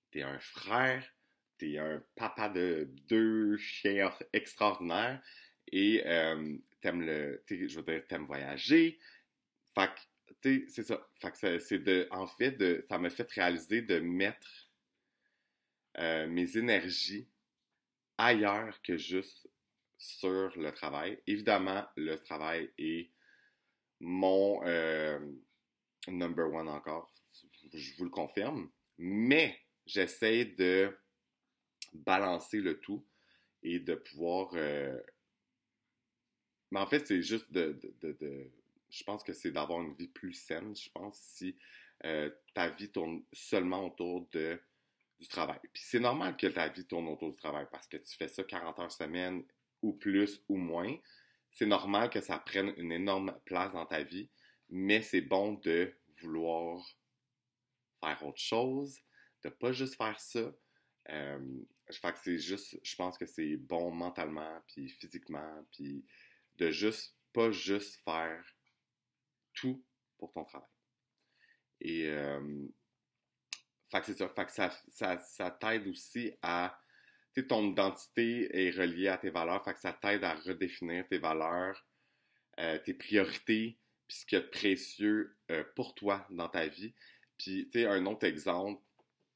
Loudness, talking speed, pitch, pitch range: -35 LUFS, 150 wpm, 95 Hz, 80-110 Hz